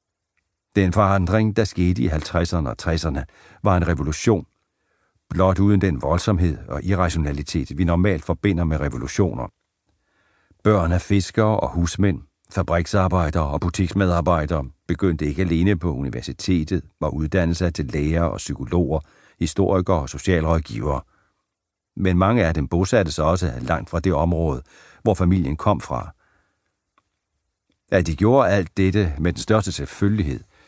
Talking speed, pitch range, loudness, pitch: 135 wpm, 80-95 Hz, -21 LUFS, 85 Hz